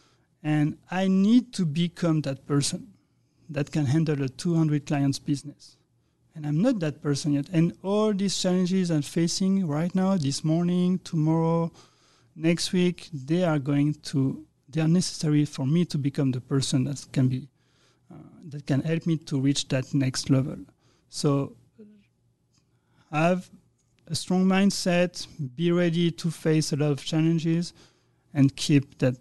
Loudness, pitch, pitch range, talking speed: -26 LUFS, 155 Hz, 140-175 Hz, 155 wpm